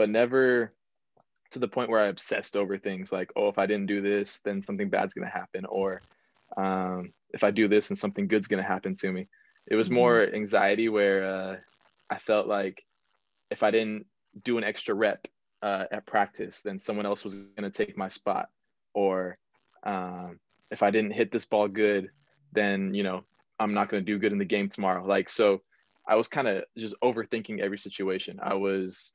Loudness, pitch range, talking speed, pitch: -28 LUFS, 95-110 Hz, 205 wpm, 100 Hz